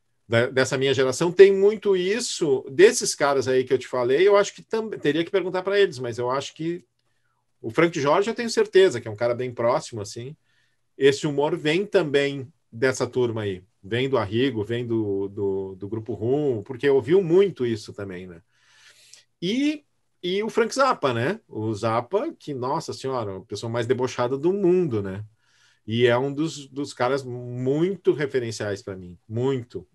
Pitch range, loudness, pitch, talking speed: 115-185 Hz, -23 LUFS, 135 Hz, 180 wpm